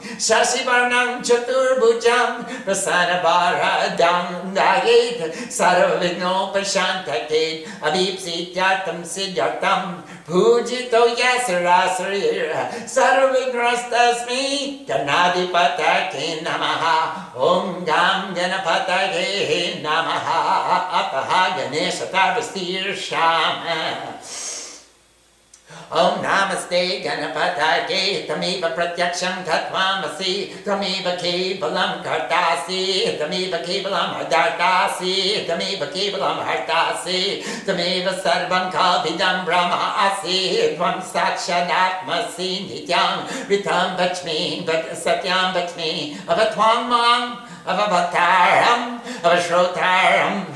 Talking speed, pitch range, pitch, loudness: 65 wpm, 175-230 Hz, 185 Hz, -19 LUFS